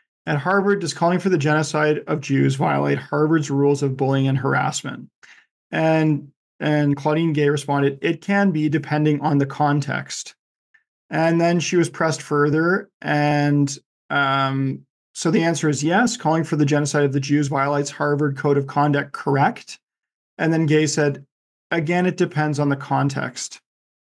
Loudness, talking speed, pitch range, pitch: -20 LUFS, 160 wpm, 140-160 Hz, 150 Hz